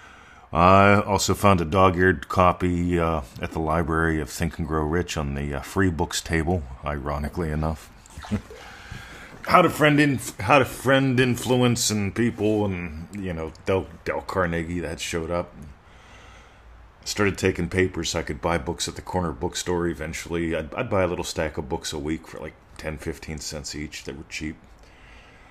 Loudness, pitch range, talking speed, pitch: -24 LUFS, 80-95 Hz, 170 wpm, 85 Hz